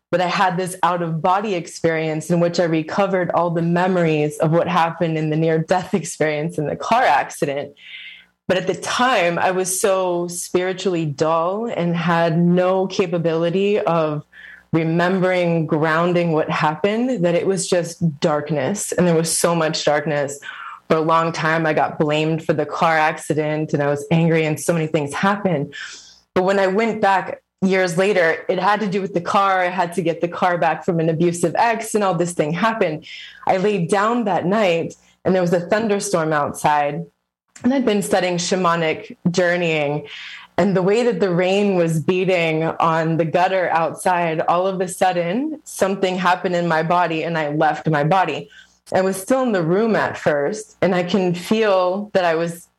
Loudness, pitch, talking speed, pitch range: -19 LUFS, 175 Hz, 185 wpm, 160-190 Hz